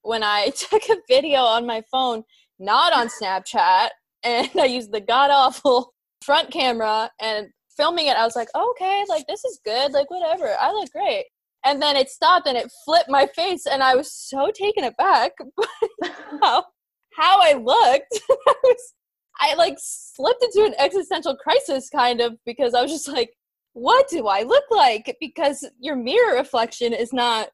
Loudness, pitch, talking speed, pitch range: -20 LUFS, 285 Hz, 180 wpm, 245-390 Hz